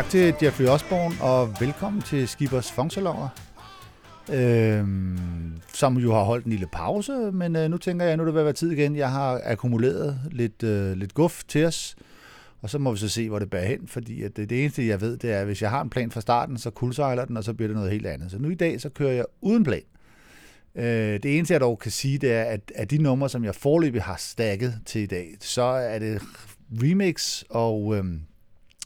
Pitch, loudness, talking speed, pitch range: 125 Hz, -25 LUFS, 230 wpm, 110-145 Hz